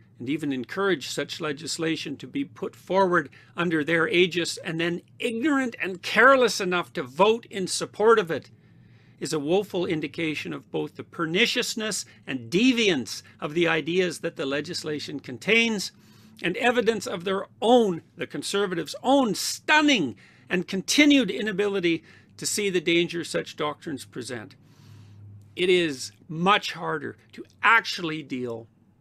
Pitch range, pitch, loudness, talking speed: 140-205 Hz, 170 Hz, -24 LUFS, 140 wpm